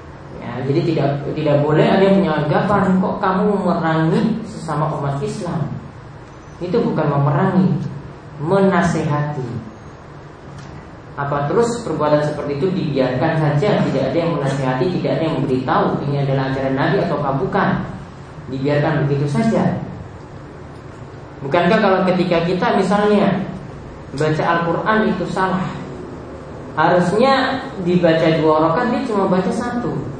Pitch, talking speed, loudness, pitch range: 160 Hz, 120 wpm, -17 LUFS, 145-190 Hz